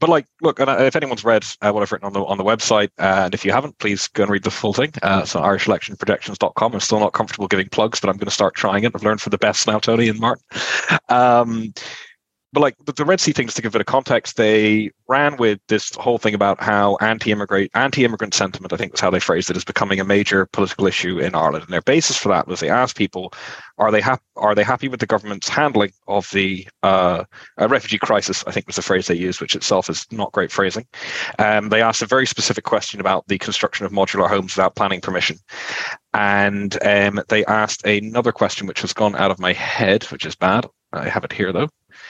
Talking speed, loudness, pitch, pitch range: 230 wpm, -18 LUFS, 105 Hz, 100-120 Hz